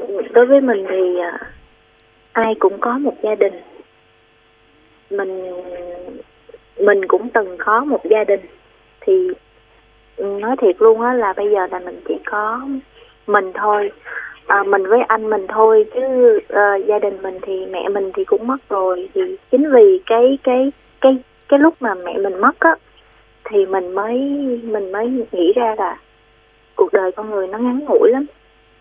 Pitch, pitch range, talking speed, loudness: 220 Hz, 200-275 Hz, 165 wpm, -16 LUFS